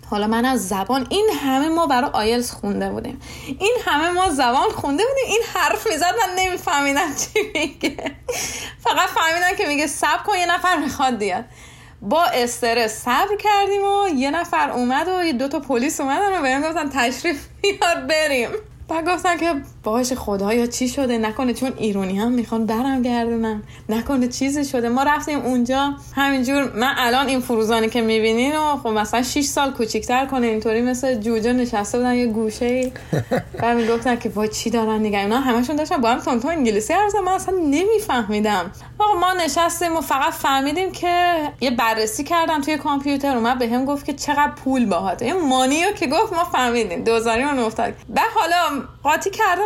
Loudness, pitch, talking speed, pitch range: -20 LUFS, 275 Hz, 180 wpm, 240-335 Hz